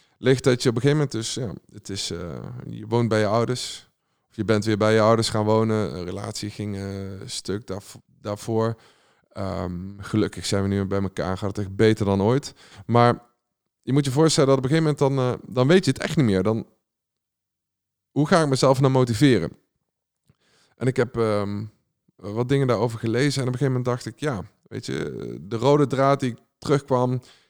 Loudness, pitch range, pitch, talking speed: -23 LUFS, 105-130 Hz, 115 Hz, 210 wpm